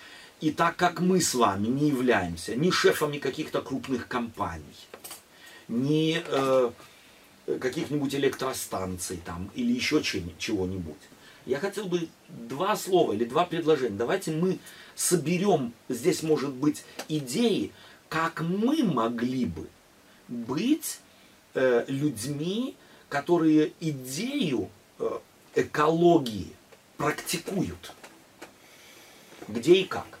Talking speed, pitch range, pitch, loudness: 105 wpm, 125-175 Hz, 155 Hz, -27 LUFS